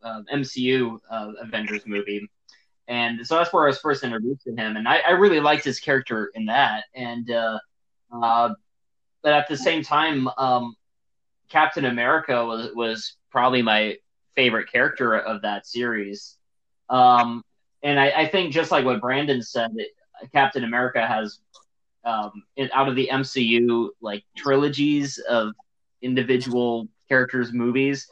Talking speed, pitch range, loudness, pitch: 145 wpm, 115-140 Hz, -22 LUFS, 125 Hz